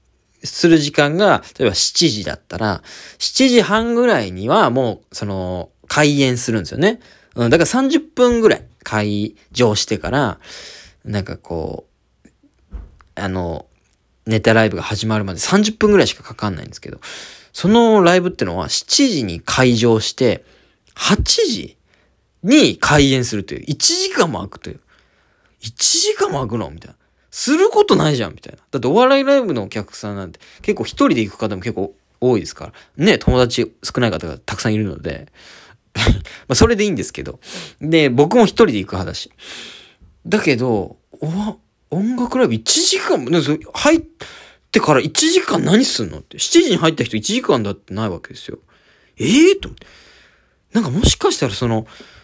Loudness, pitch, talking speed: -16 LUFS, 140 Hz, 310 characters per minute